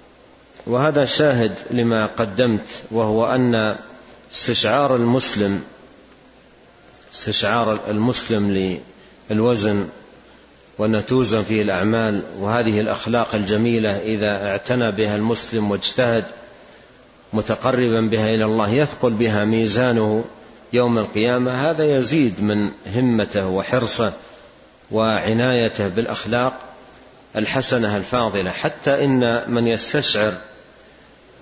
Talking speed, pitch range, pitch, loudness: 85 wpm, 105-125 Hz, 115 Hz, -19 LUFS